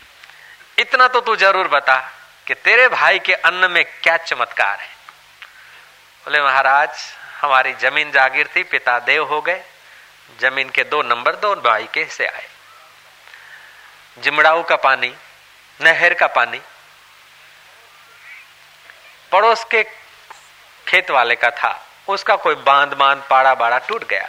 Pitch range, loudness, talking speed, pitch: 130-200 Hz, -15 LUFS, 130 wpm, 150 Hz